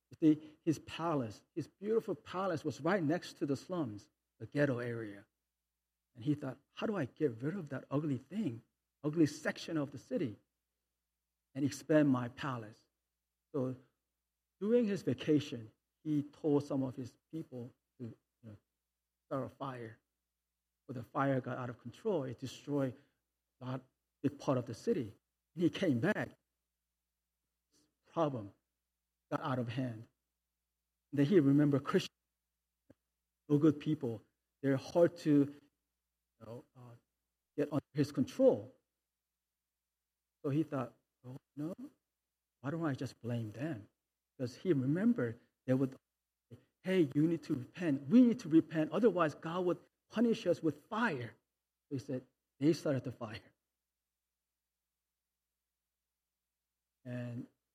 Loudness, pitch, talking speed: -36 LUFS, 125 Hz, 140 wpm